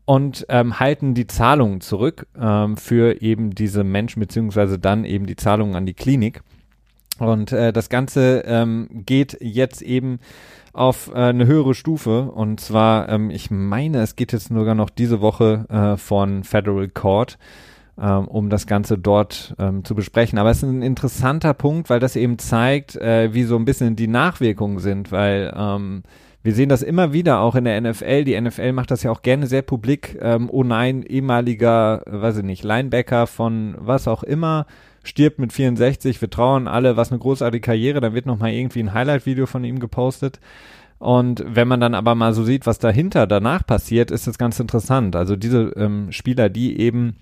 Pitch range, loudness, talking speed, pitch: 110-130 Hz, -19 LUFS, 185 wpm, 115 Hz